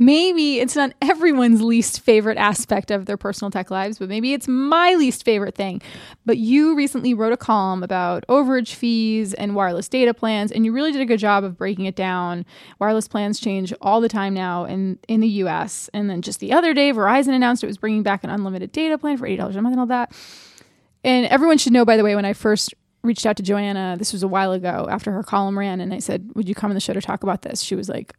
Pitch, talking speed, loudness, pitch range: 215 Hz, 245 wpm, -19 LUFS, 195-250 Hz